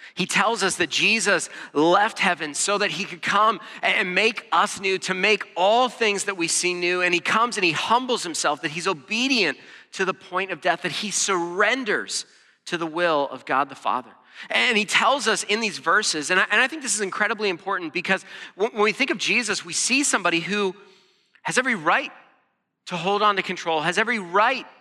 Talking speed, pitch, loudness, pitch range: 210 wpm, 195 Hz, -22 LUFS, 175-215 Hz